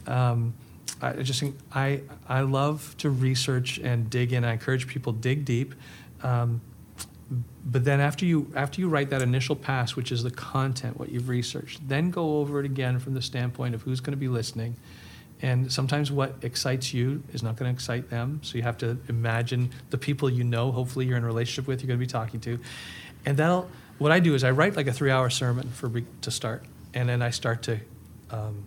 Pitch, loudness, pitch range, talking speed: 125 Hz, -27 LUFS, 120-140 Hz, 220 wpm